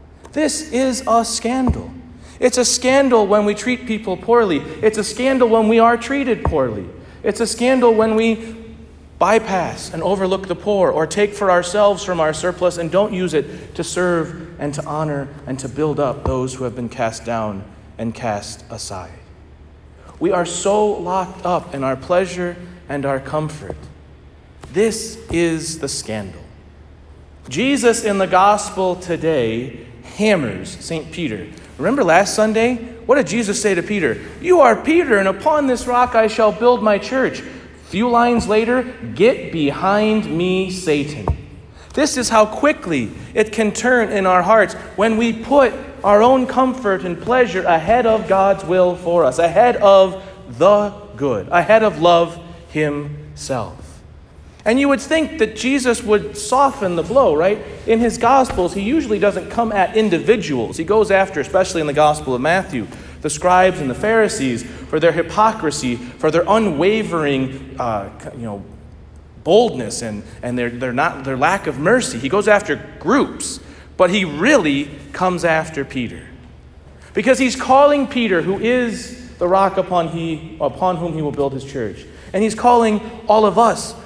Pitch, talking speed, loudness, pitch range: 190 Hz, 165 wpm, -17 LUFS, 150-225 Hz